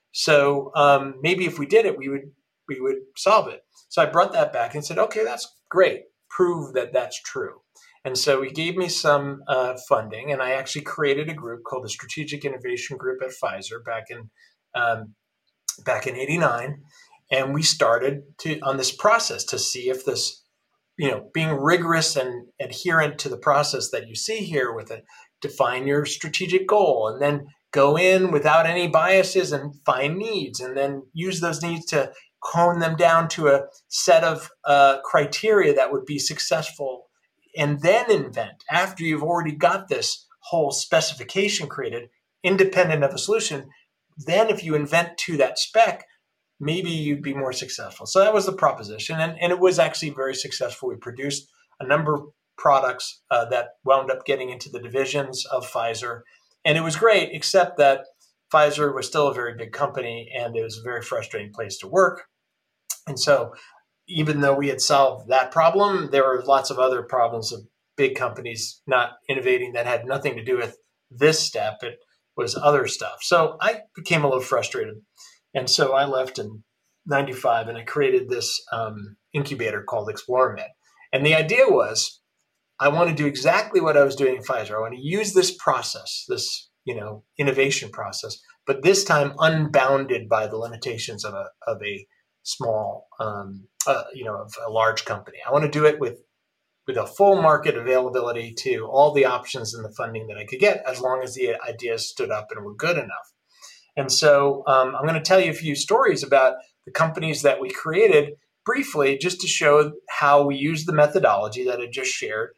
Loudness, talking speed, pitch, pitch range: -22 LUFS, 185 wpm, 145 Hz, 130-180 Hz